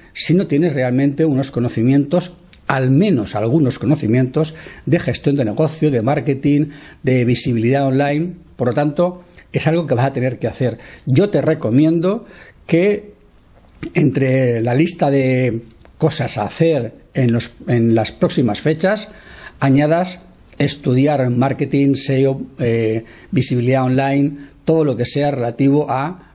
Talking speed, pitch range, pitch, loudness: 135 wpm, 125-160 Hz, 140 Hz, -17 LUFS